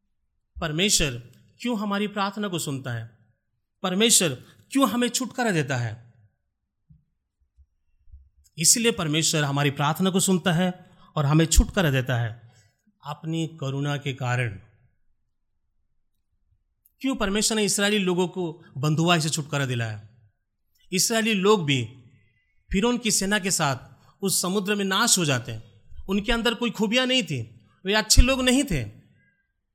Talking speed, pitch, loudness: 130 wpm, 155 Hz, -23 LUFS